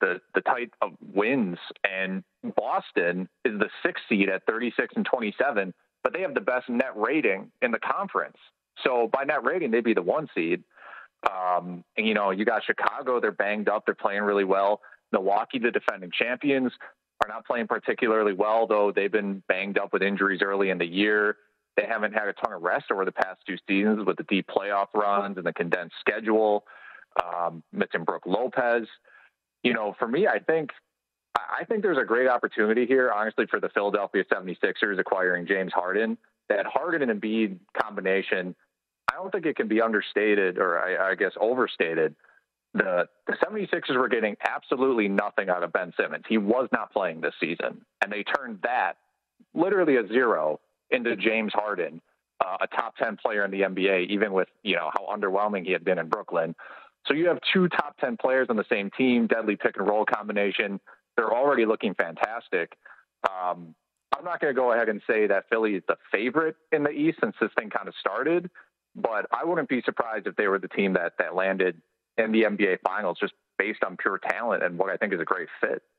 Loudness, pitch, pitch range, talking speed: -26 LUFS, 105 Hz, 95-115 Hz, 195 wpm